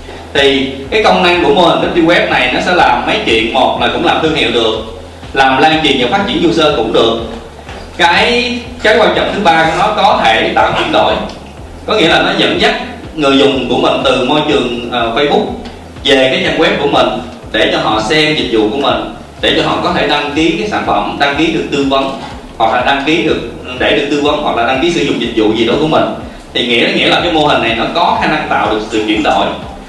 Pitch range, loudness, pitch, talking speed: 120-155 Hz, -11 LUFS, 135 Hz, 255 wpm